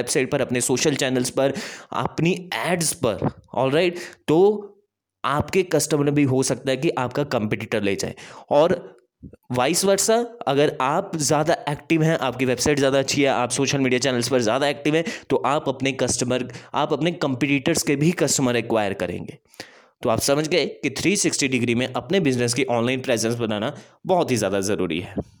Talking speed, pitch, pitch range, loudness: 175 wpm, 140 Hz, 125-160 Hz, -22 LUFS